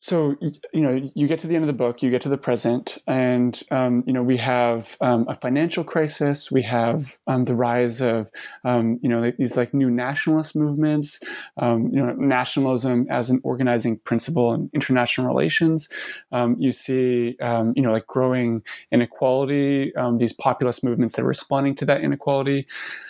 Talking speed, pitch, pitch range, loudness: 180 wpm, 130 Hz, 120-140 Hz, -22 LUFS